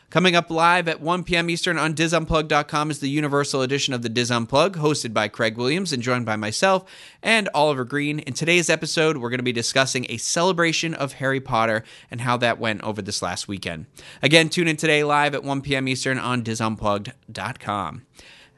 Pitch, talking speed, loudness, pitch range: 135 Hz, 190 wpm, -21 LUFS, 115-160 Hz